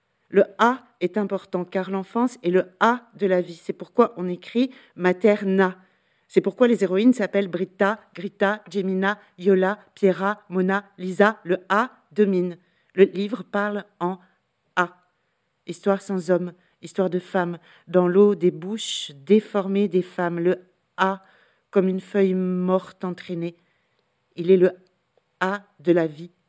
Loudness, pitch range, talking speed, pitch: -23 LUFS, 180-200 Hz, 145 wpm, 190 Hz